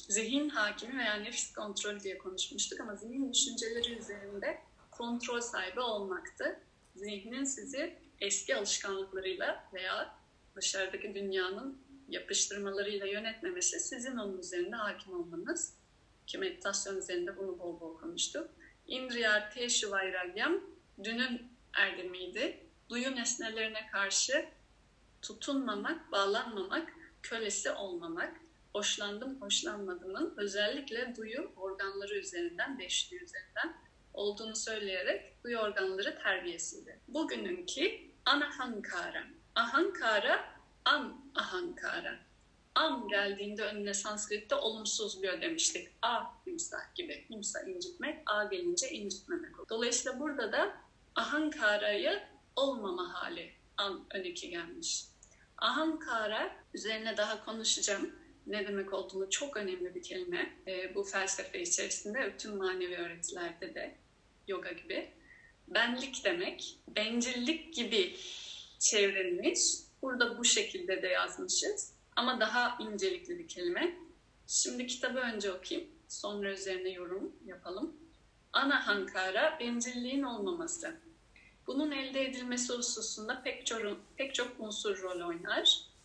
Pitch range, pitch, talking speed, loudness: 200-315 Hz, 240 Hz, 105 wpm, -35 LUFS